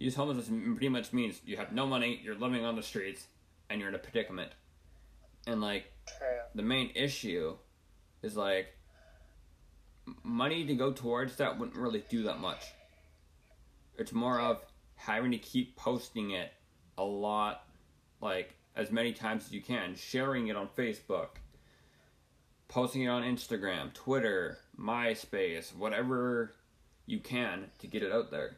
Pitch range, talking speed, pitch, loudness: 80-130 Hz, 150 wpm, 115 Hz, -35 LUFS